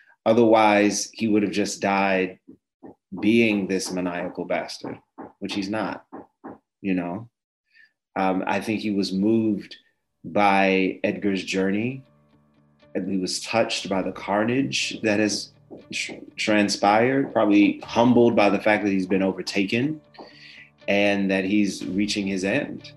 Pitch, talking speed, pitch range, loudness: 100 Hz, 130 wpm, 95-110 Hz, -22 LUFS